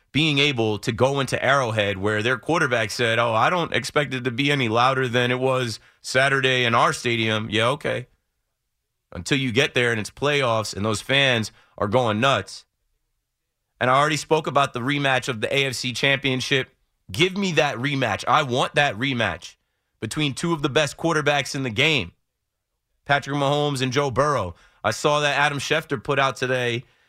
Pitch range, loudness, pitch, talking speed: 120-145 Hz, -21 LUFS, 130 Hz, 180 wpm